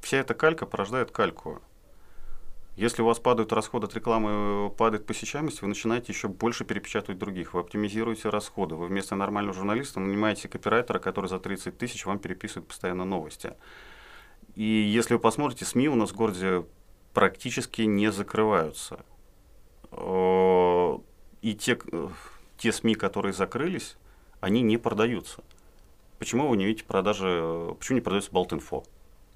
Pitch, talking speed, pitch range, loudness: 105 Hz, 140 wpm, 95-115 Hz, -28 LUFS